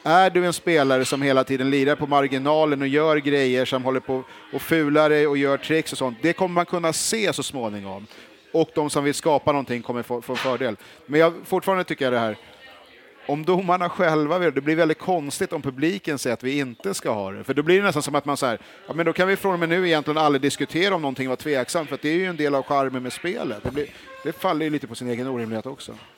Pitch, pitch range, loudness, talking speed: 145 Hz, 130-165 Hz, -22 LUFS, 260 wpm